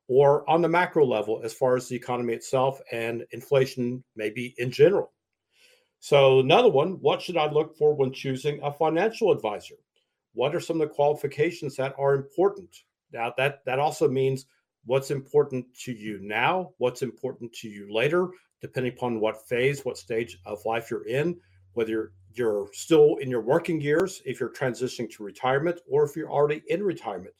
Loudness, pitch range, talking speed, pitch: -25 LUFS, 120-160 Hz, 180 wpm, 135 Hz